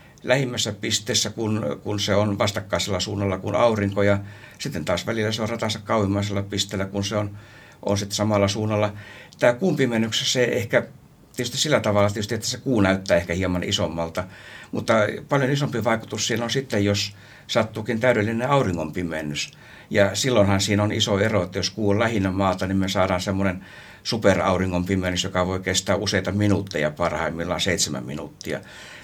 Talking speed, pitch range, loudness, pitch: 160 wpm, 95-110 Hz, -23 LUFS, 105 Hz